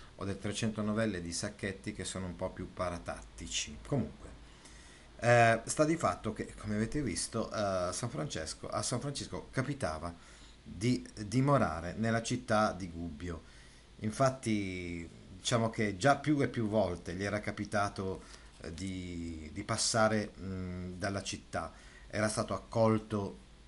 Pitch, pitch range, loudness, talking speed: 105 Hz, 90-115 Hz, -34 LUFS, 135 wpm